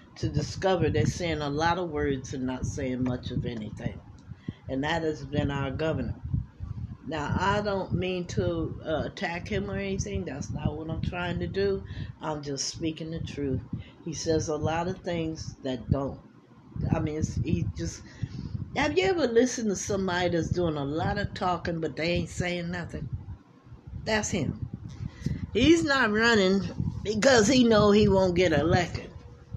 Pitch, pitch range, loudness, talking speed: 155 Hz, 130-180 Hz, -28 LUFS, 170 wpm